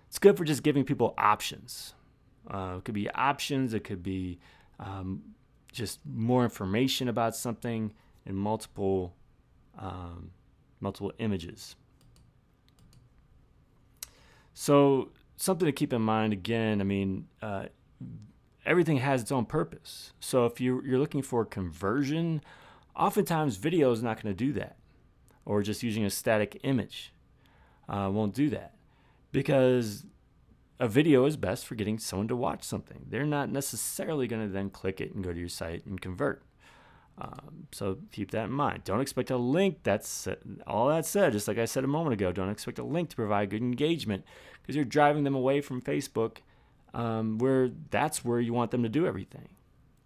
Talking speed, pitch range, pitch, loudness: 165 wpm, 100-135 Hz, 115 Hz, -30 LUFS